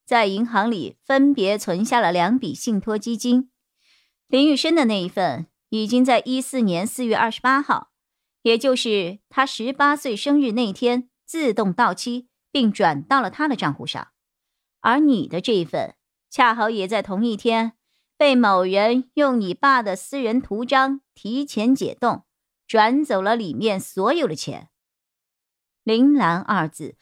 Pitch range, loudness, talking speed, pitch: 210-265 Hz, -20 LUFS, 220 characters per minute, 235 Hz